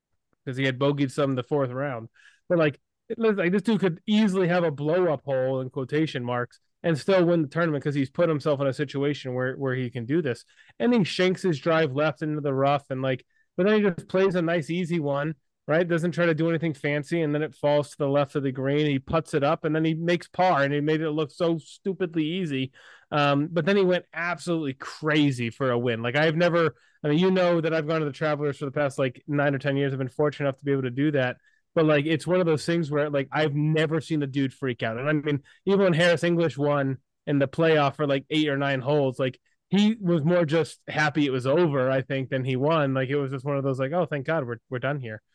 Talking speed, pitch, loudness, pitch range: 265 wpm, 150 Hz, -25 LUFS, 135-170 Hz